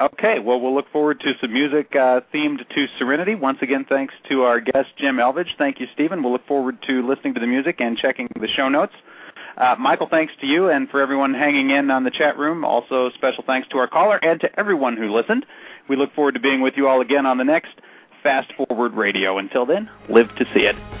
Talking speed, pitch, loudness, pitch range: 235 wpm, 135 Hz, -19 LUFS, 125-150 Hz